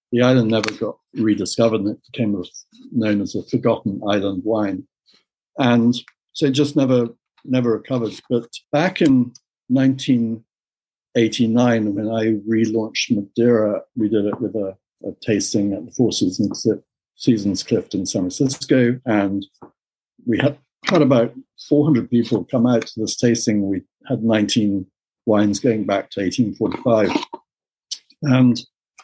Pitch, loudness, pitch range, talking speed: 115 Hz, -19 LUFS, 105-125 Hz, 135 wpm